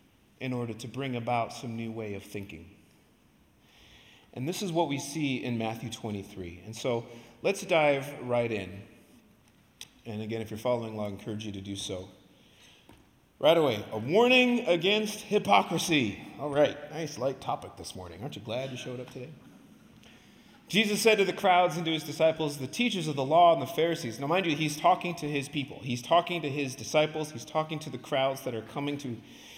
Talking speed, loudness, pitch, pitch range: 195 wpm, -29 LUFS, 135 Hz, 115-160 Hz